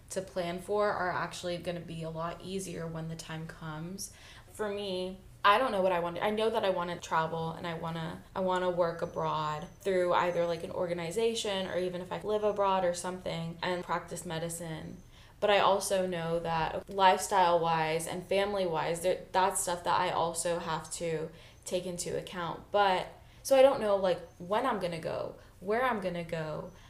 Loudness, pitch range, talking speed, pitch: -32 LUFS, 165-190 Hz, 200 wpm, 175 Hz